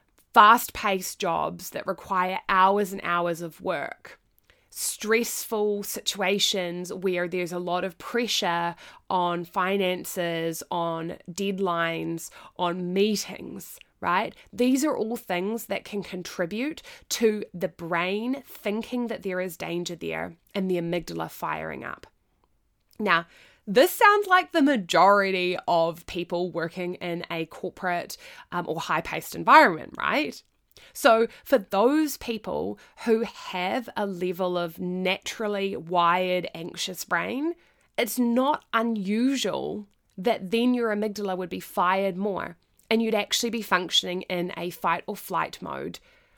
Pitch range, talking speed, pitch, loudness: 175-225 Hz, 125 wpm, 190 Hz, -26 LUFS